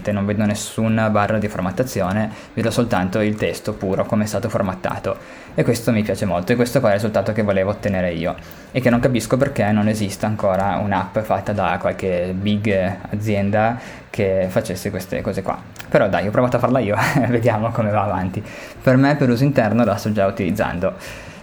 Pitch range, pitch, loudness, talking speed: 95-115 Hz, 105 Hz, -19 LUFS, 195 wpm